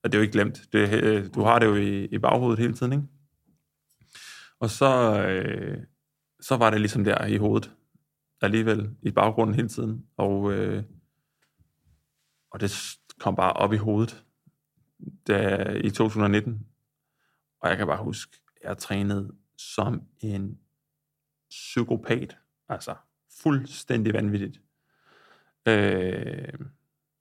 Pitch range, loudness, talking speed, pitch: 100-135 Hz, -25 LUFS, 125 wpm, 110 Hz